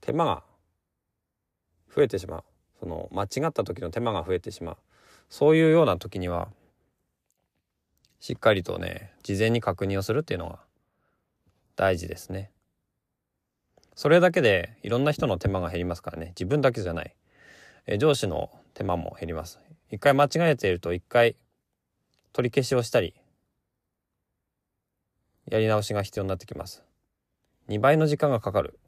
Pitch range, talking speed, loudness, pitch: 90-120 Hz, 295 characters per minute, -25 LUFS, 100 Hz